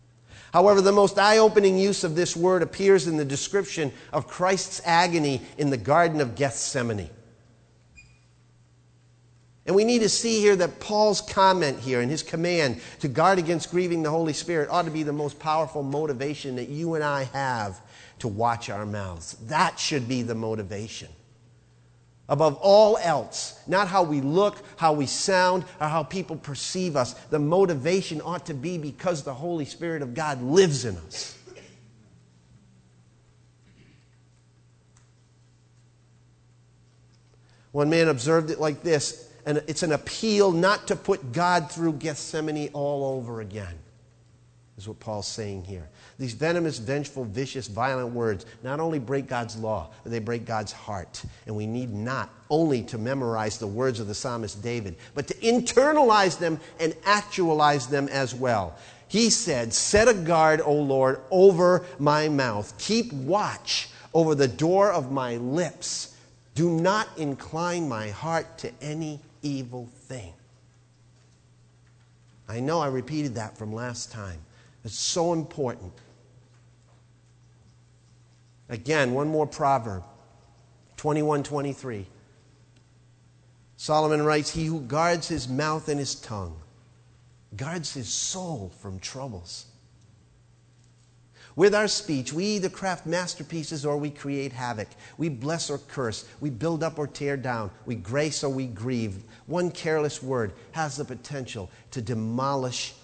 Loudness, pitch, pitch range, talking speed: -25 LUFS, 135 Hz, 115-160 Hz, 145 wpm